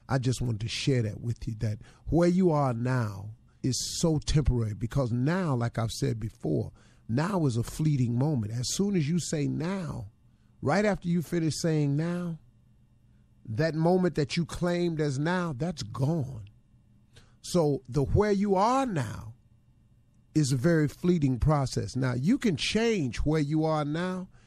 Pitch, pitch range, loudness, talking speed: 140 Hz, 120-165 Hz, -28 LUFS, 165 wpm